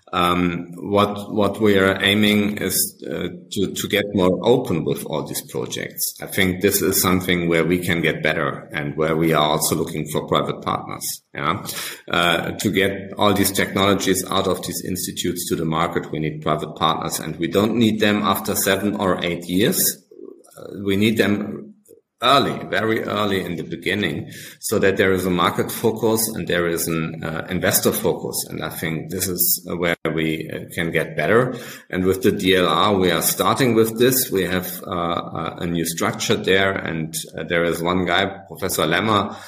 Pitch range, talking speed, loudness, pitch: 85-100 Hz, 190 wpm, -20 LUFS, 95 Hz